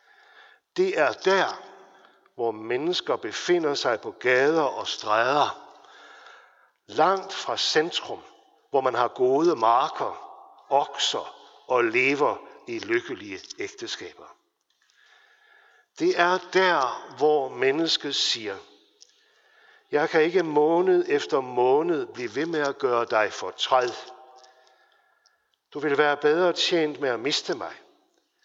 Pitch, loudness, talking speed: 355 Hz, -24 LUFS, 115 wpm